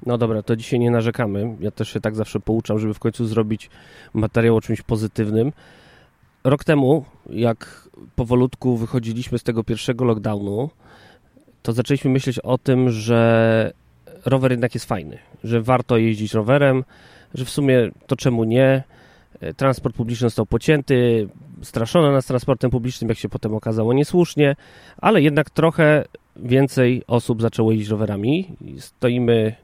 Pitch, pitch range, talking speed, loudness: 120 Hz, 110-130 Hz, 145 wpm, -20 LUFS